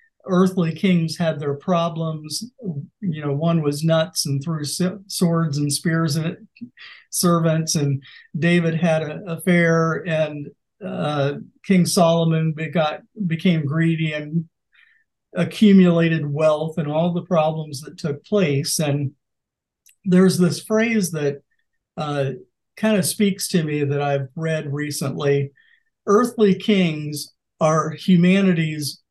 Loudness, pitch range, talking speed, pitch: -20 LUFS, 150-185 Hz, 120 wpm, 165 Hz